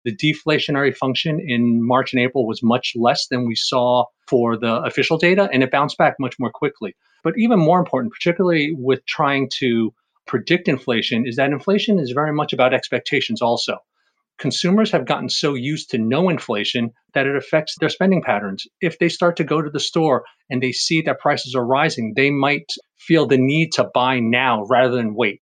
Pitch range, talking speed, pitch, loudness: 125-160 Hz, 195 wpm, 135 Hz, -19 LUFS